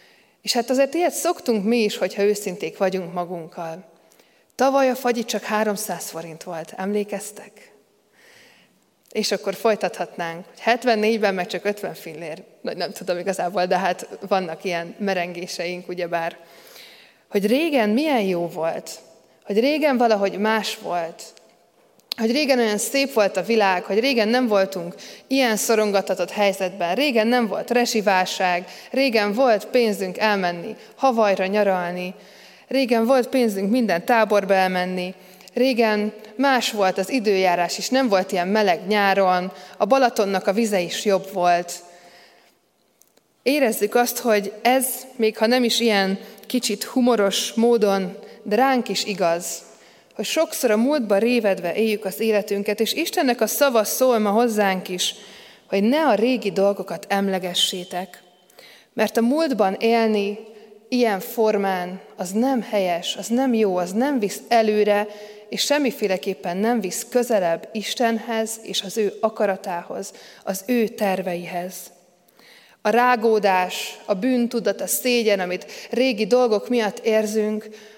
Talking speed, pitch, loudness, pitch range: 135 wpm, 210 Hz, -21 LUFS, 185-235 Hz